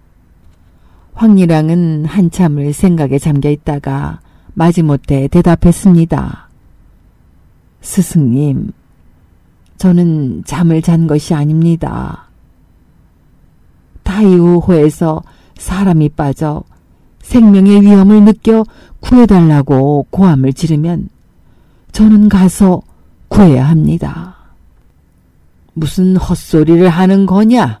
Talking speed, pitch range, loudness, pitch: 190 characters per minute, 110-180 Hz, -10 LUFS, 155 Hz